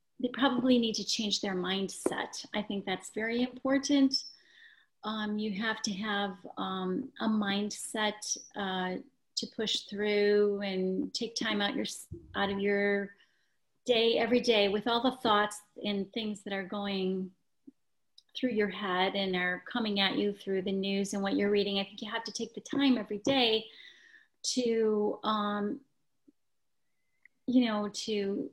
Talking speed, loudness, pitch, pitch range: 155 wpm, -31 LUFS, 210 Hz, 200-245 Hz